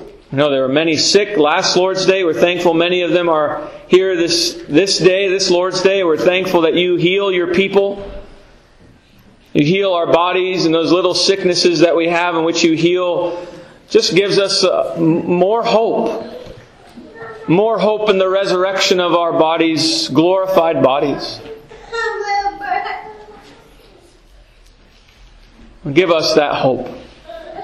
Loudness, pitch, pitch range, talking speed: -14 LUFS, 180 Hz, 170-200 Hz, 135 wpm